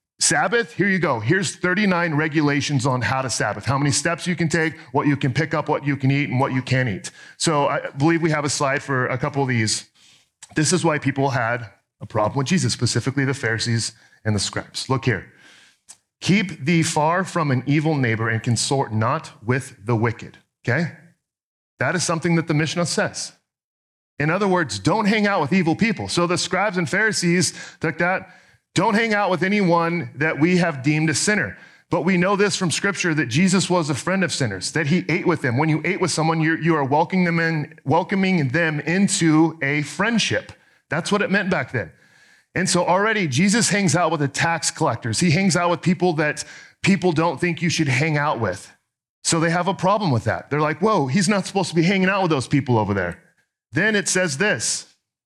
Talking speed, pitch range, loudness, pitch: 215 wpm, 135-180 Hz, -20 LUFS, 160 Hz